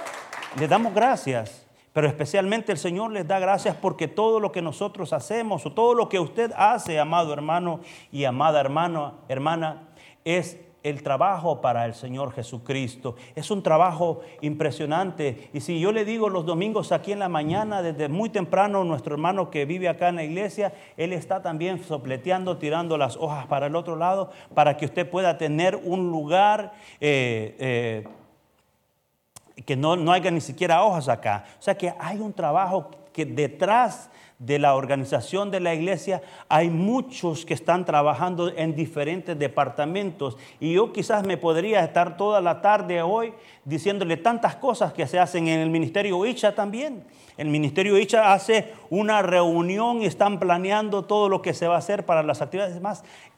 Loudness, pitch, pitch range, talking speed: -24 LUFS, 170 Hz, 150-195 Hz, 170 wpm